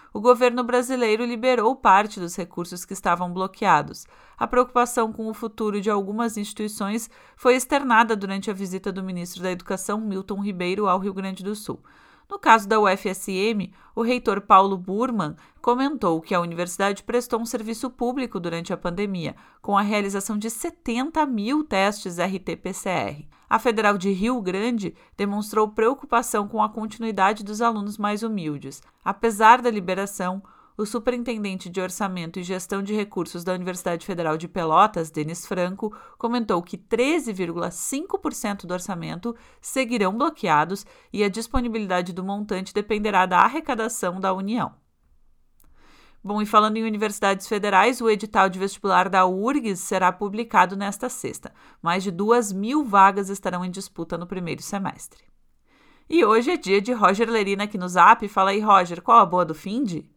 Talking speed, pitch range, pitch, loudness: 155 wpm, 185-230 Hz, 205 Hz, -23 LUFS